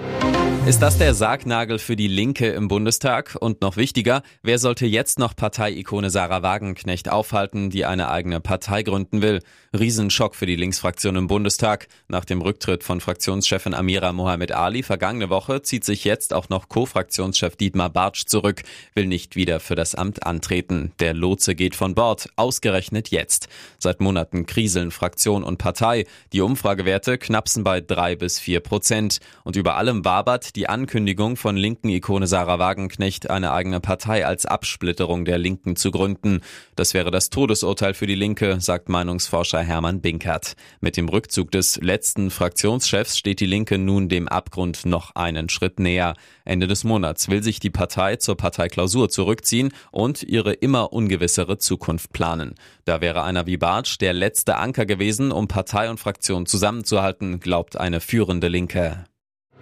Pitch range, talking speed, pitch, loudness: 90-105 Hz, 160 wpm, 95 Hz, -21 LUFS